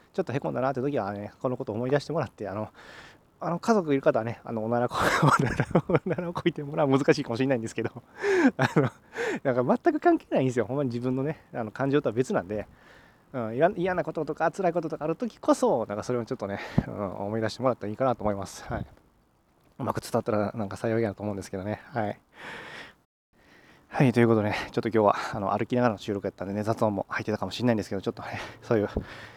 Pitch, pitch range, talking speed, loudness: 120 Hz, 105-150 Hz, 480 characters per minute, -28 LUFS